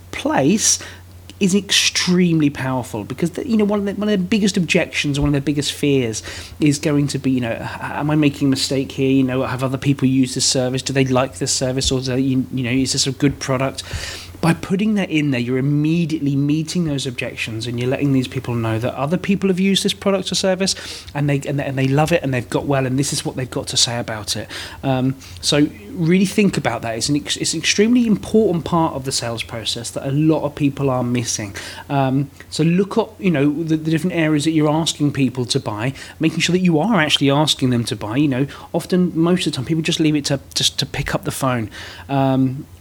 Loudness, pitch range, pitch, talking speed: -18 LUFS, 130-160 Hz, 140 Hz, 240 wpm